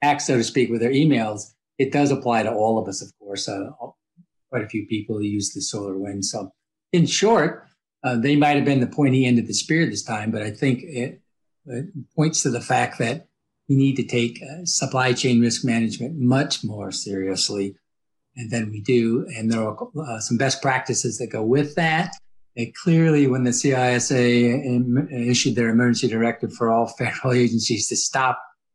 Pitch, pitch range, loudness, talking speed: 120 Hz, 110-140 Hz, -21 LUFS, 190 wpm